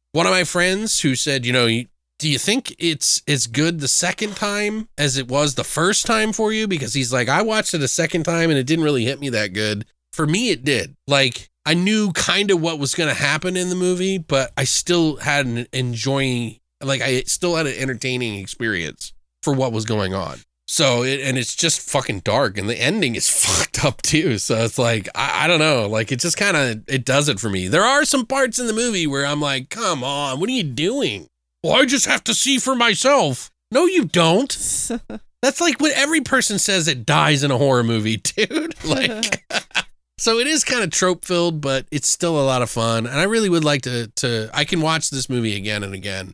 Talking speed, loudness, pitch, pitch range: 230 wpm, -18 LUFS, 145 Hz, 125-190 Hz